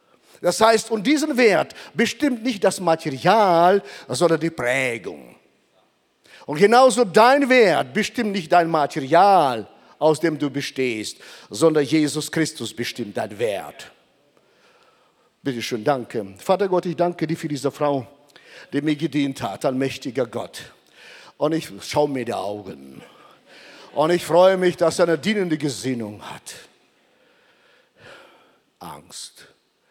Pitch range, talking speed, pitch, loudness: 140-195 Hz, 130 wpm, 160 Hz, -20 LUFS